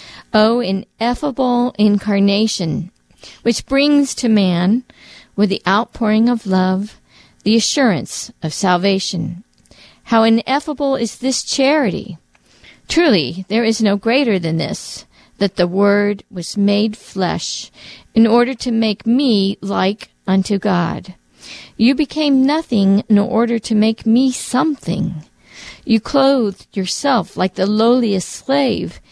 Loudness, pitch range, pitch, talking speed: -16 LUFS, 195-250 Hz, 220 Hz, 120 wpm